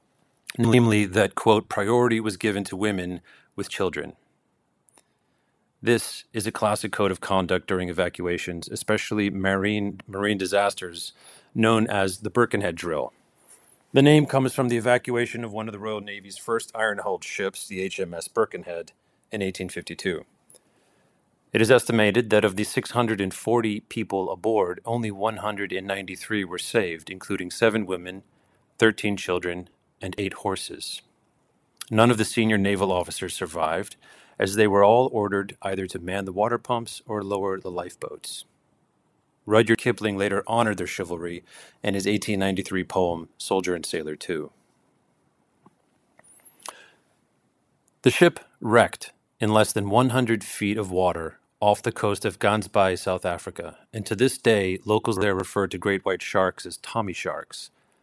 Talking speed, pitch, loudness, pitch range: 140 wpm, 105 Hz, -24 LUFS, 95-110 Hz